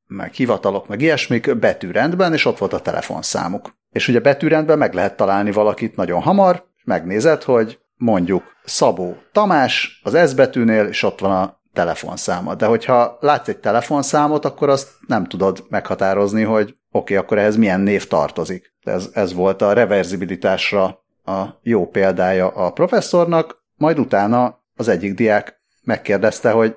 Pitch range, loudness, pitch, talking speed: 100-145 Hz, -17 LUFS, 110 Hz, 150 wpm